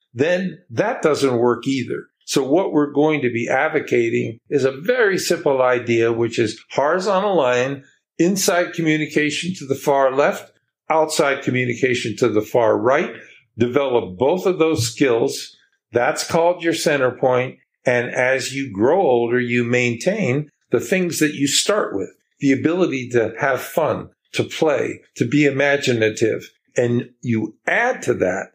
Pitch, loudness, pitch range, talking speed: 135 Hz, -19 LUFS, 120-155 Hz, 150 wpm